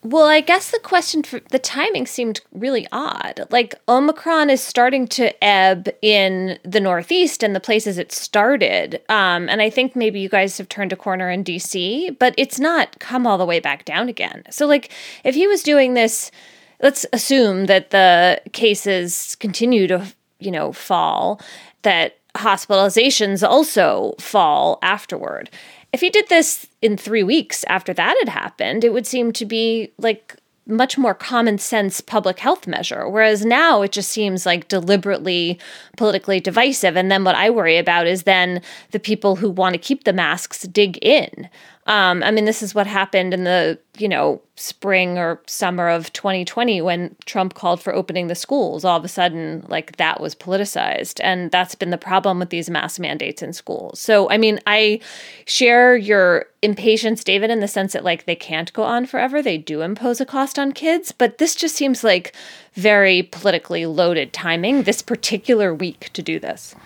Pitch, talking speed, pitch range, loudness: 210 Hz, 180 wpm, 185-245 Hz, -17 LUFS